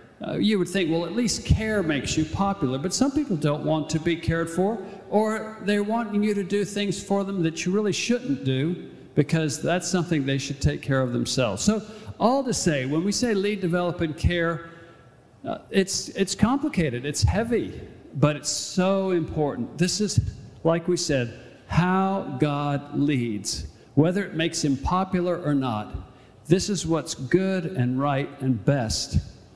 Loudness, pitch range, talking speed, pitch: -25 LUFS, 140-195 Hz, 175 wpm, 165 Hz